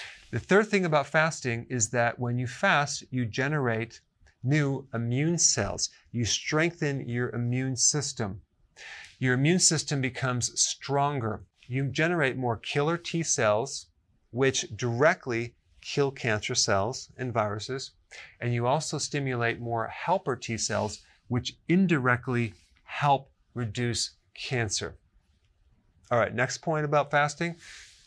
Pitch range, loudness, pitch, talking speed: 115-145 Hz, -27 LUFS, 125 Hz, 120 wpm